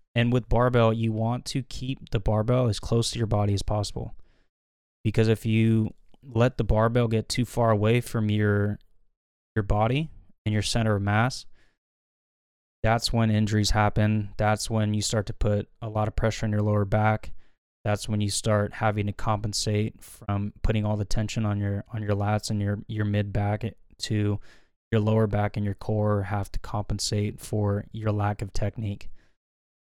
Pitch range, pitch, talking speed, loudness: 105-115 Hz, 105 Hz, 180 wpm, -26 LUFS